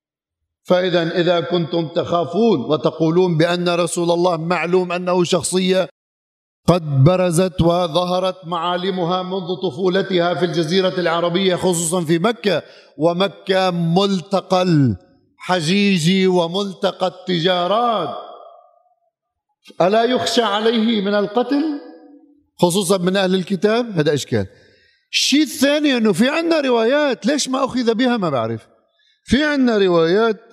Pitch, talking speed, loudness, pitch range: 185 Hz, 105 wpm, -17 LUFS, 175-230 Hz